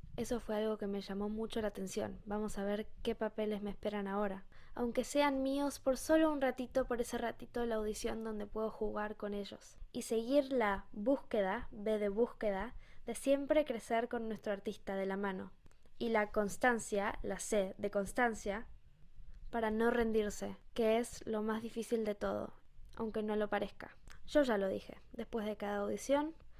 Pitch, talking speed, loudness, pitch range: 220 Hz, 180 wpm, -37 LUFS, 205-240 Hz